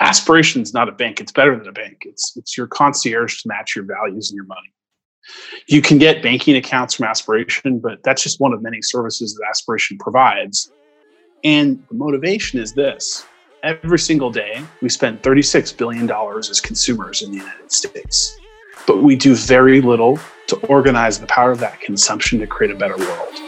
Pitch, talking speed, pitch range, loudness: 140 Hz, 185 wpm, 120-175 Hz, -16 LUFS